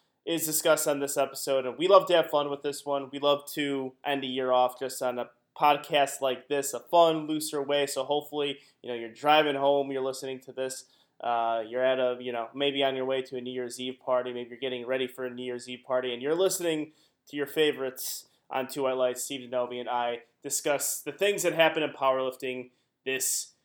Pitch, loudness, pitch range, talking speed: 135 Hz, -28 LUFS, 125-145 Hz, 230 wpm